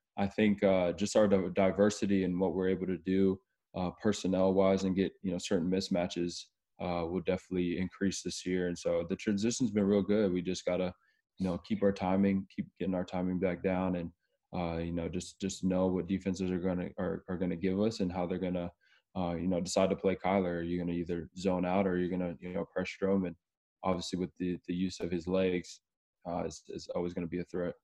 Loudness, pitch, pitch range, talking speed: -33 LUFS, 90 Hz, 90-95 Hz, 225 wpm